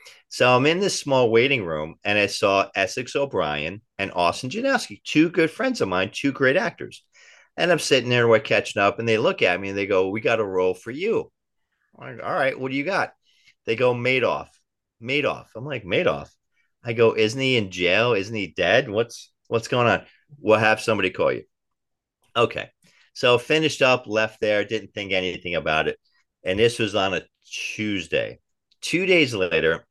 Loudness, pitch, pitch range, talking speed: -22 LUFS, 115 Hz, 100-135 Hz, 200 wpm